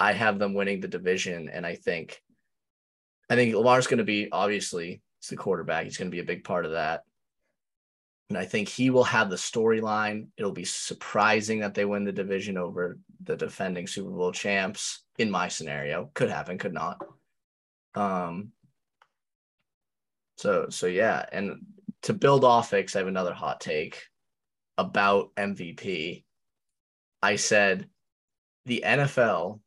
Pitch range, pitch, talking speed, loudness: 95-125 Hz, 105 Hz, 155 wpm, -27 LUFS